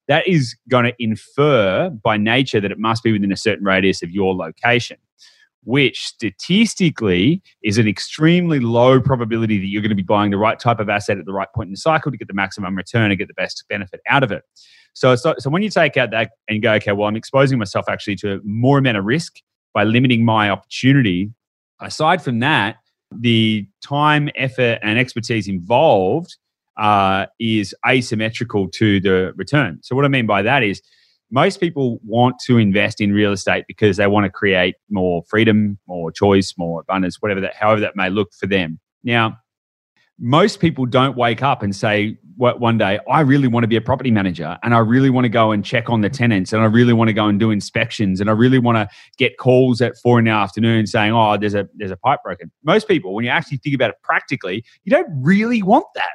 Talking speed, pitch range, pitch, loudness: 215 wpm, 100-130 Hz, 115 Hz, -17 LUFS